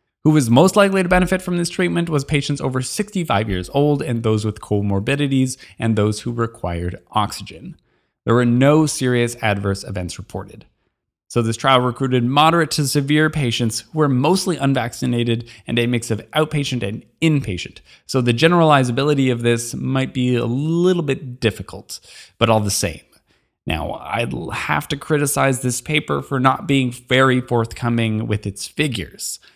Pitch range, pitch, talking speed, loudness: 115-145 Hz, 125 Hz, 160 wpm, -19 LUFS